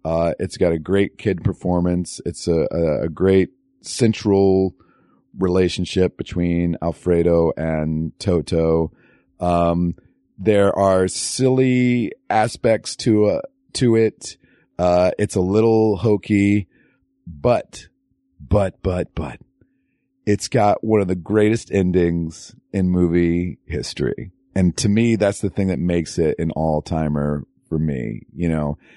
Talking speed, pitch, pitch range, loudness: 125 wpm, 90 Hz, 85-105 Hz, -20 LUFS